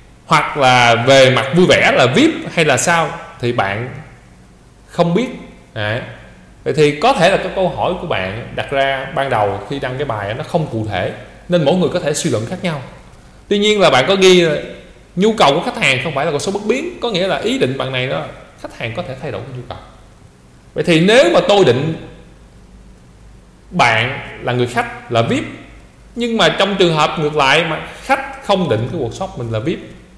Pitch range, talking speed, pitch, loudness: 120-185 Hz, 220 wpm, 145 Hz, -15 LUFS